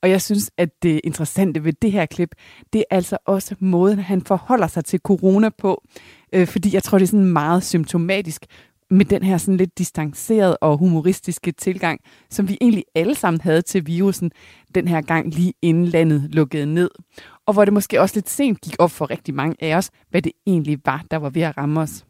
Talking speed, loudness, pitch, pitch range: 210 wpm, -19 LUFS, 180 Hz, 165-195 Hz